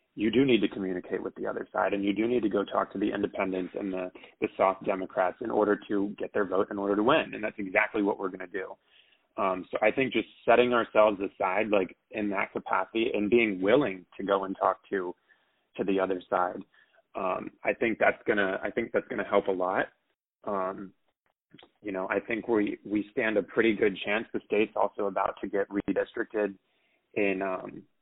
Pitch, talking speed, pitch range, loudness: 100 Hz, 210 wpm, 95-105 Hz, -29 LUFS